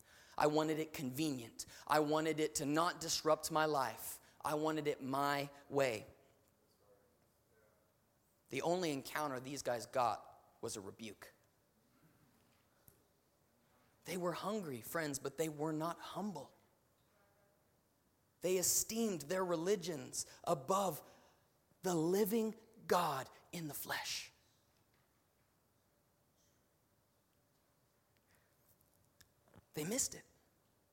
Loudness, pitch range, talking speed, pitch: -39 LUFS, 125-170 Hz, 95 wpm, 150 Hz